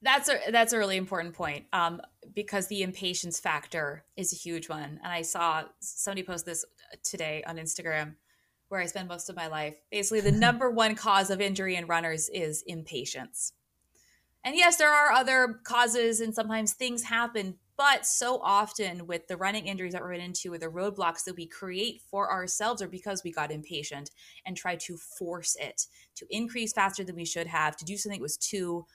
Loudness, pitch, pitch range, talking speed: -29 LUFS, 185 Hz, 170-215 Hz, 195 wpm